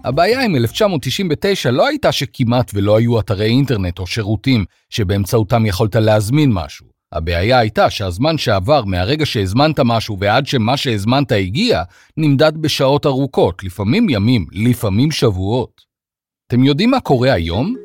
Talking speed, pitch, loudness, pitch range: 130 wpm, 120 Hz, -15 LUFS, 105-140 Hz